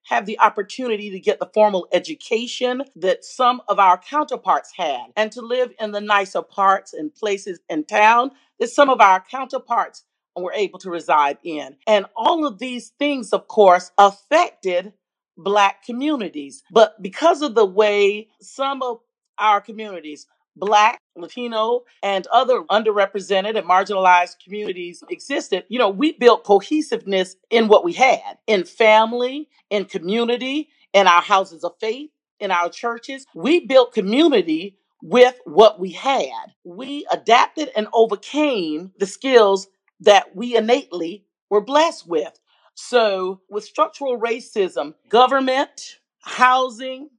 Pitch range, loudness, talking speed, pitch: 195-260 Hz, -18 LUFS, 140 wpm, 220 Hz